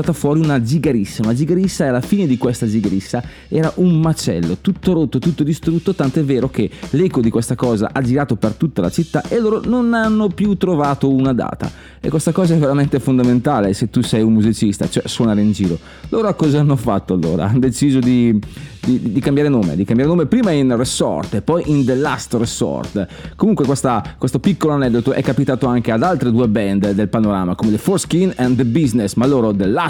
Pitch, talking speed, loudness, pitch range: 135 Hz, 210 wpm, -16 LUFS, 115-165 Hz